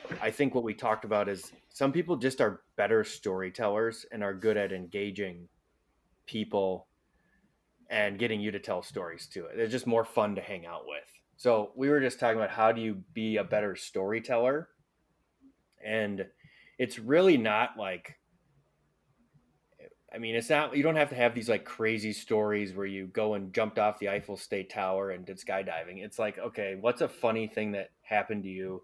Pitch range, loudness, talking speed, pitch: 100-120 Hz, -31 LUFS, 185 wpm, 110 Hz